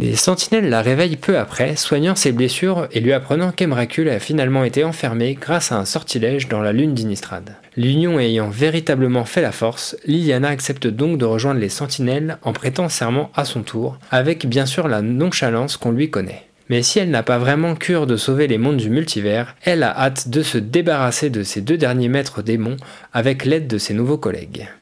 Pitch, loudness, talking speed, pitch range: 135 Hz, -18 LUFS, 200 wpm, 120-155 Hz